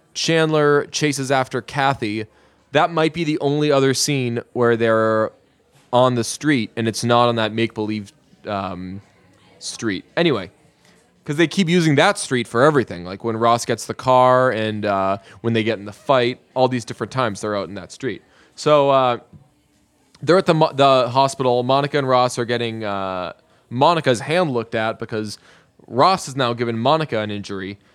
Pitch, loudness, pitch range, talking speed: 120 Hz, -19 LUFS, 110-140 Hz, 180 wpm